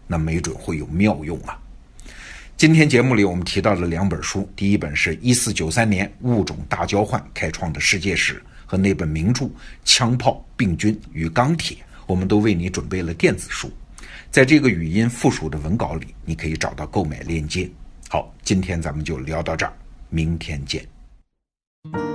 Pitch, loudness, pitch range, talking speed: 90 Hz, -20 LUFS, 80-110 Hz, 265 characters per minute